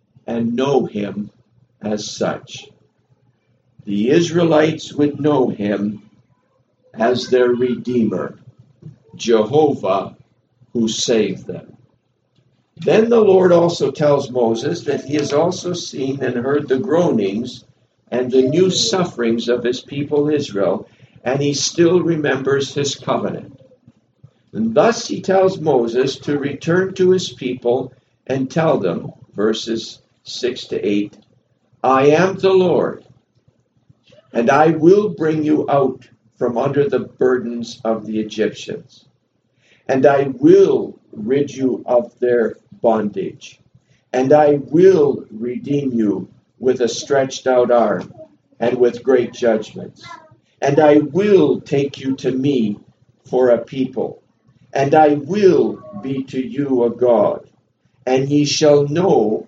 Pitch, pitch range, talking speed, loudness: 135 Hz, 120-150 Hz, 125 wpm, -17 LUFS